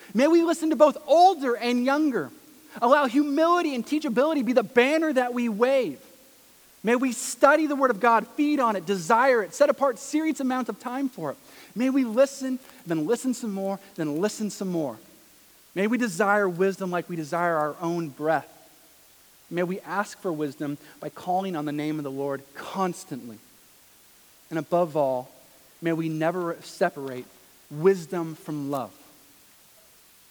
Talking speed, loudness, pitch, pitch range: 165 wpm, -25 LUFS, 210 Hz, 165-265 Hz